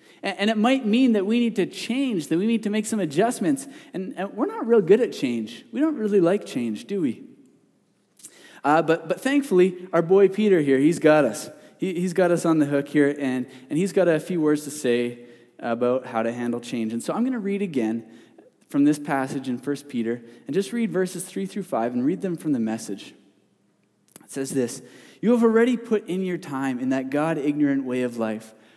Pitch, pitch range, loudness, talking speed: 160 Hz, 125-200 Hz, -23 LUFS, 220 wpm